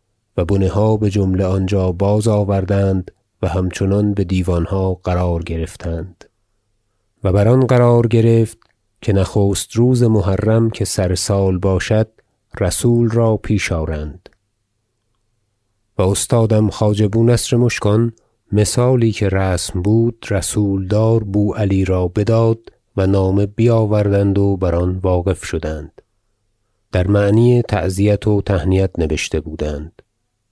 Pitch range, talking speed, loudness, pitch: 95-110 Hz, 120 wpm, -16 LUFS, 100 Hz